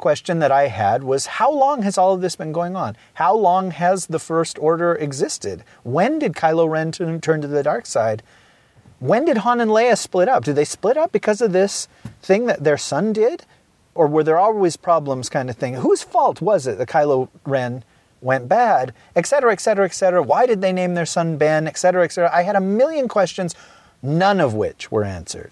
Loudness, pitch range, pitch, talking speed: -18 LUFS, 145-195 Hz, 170 Hz, 215 wpm